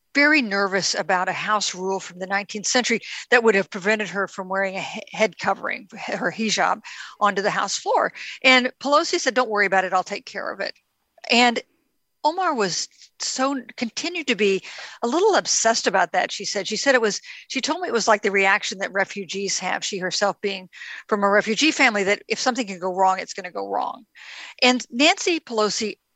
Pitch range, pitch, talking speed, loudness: 195-255 Hz, 215 Hz, 200 wpm, -21 LUFS